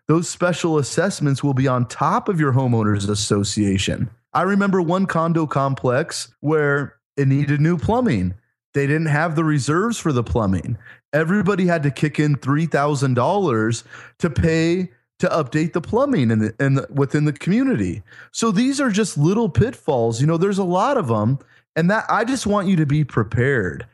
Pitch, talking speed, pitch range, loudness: 150 Hz, 180 wpm, 125-175 Hz, -20 LUFS